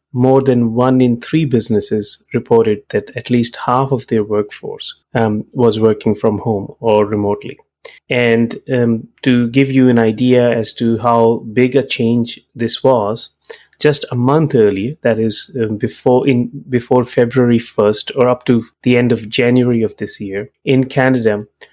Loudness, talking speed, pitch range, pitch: -14 LUFS, 165 wpm, 110-130 Hz, 120 Hz